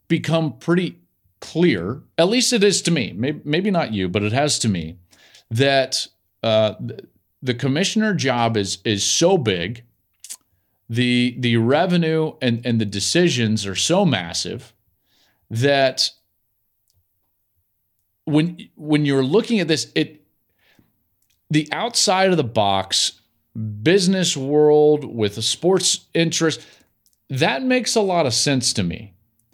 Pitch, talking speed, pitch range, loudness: 130 Hz, 130 wpm, 110-165 Hz, -19 LUFS